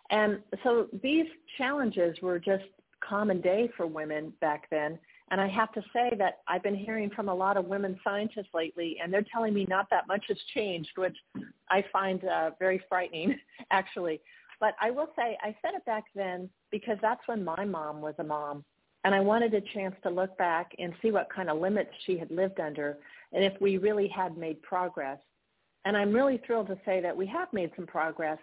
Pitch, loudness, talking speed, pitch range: 195 Hz, -31 LUFS, 205 wpm, 175-215 Hz